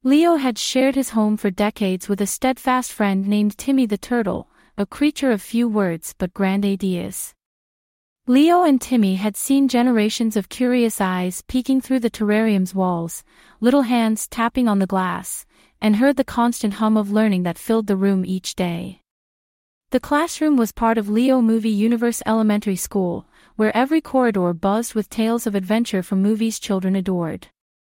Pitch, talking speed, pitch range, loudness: 220 Hz, 165 wpm, 195-250 Hz, -20 LUFS